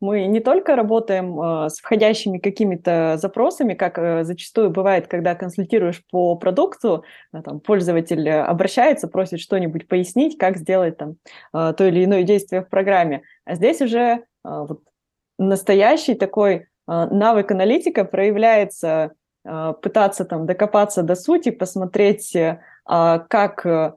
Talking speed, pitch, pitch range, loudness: 115 wpm, 190 Hz, 170-205 Hz, -19 LUFS